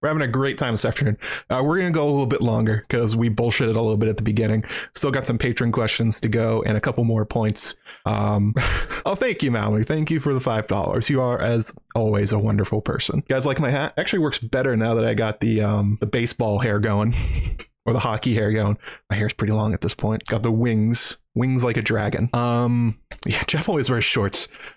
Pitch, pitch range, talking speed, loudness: 115 Hz, 110-125 Hz, 235 wpm, -22 LUFS